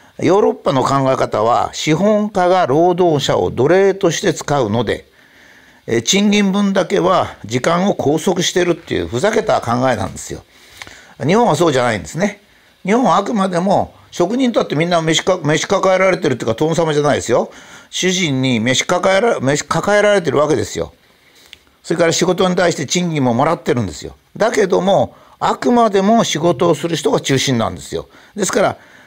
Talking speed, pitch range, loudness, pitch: 360 characters per minute, 150-190 Hz, -15 LUFS, 175 Hz